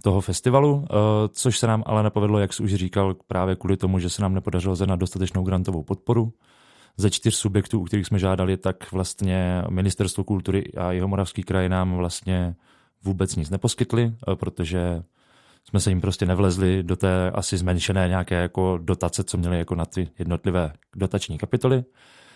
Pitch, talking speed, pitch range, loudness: 95 Hz, 170 wpm, 90-105 Hz, -24 LUFS